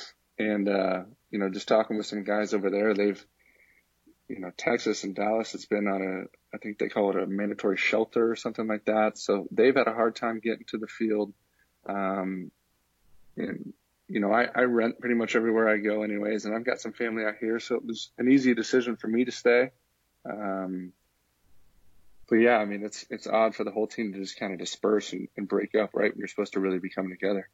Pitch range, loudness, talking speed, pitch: 95-115 Hz, -28 LUFS, 220 wpm, 105 Hz